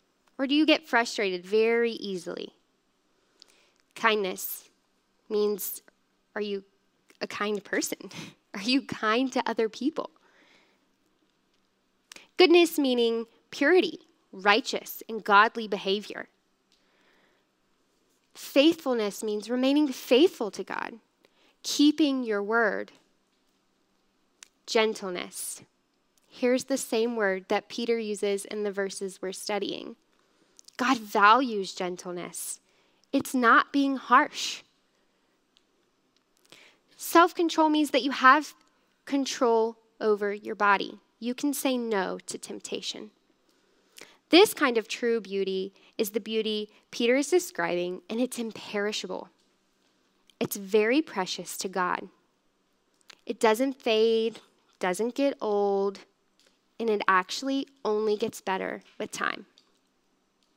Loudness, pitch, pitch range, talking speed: -27 LUFS, 225 Hz, 205-270 Hz, 105 wpm